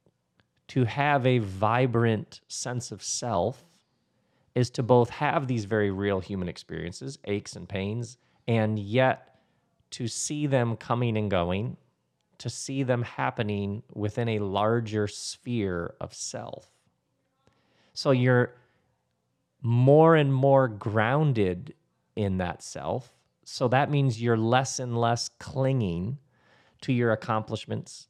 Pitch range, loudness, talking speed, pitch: 105-130 Hz, -27 LUFS, 120 wpm, 115 Hz